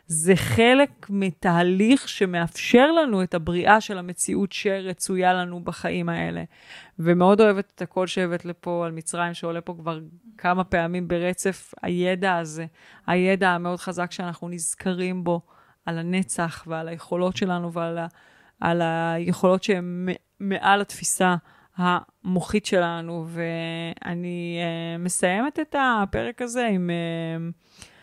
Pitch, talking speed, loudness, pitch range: 180 Hz, 120 wpm, -24 LUFS, 170-190 Hz